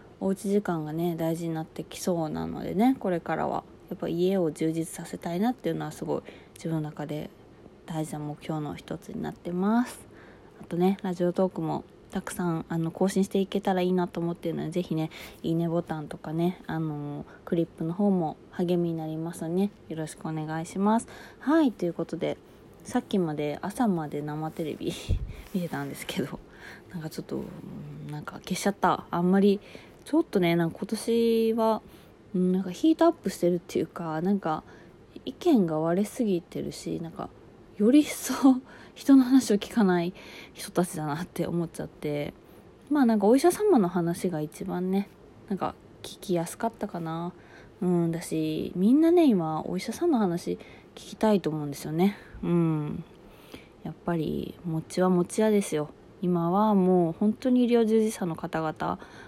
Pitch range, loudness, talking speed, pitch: 160-205 Hz, -28 LUFS, 345 characters per minute, 180 Hz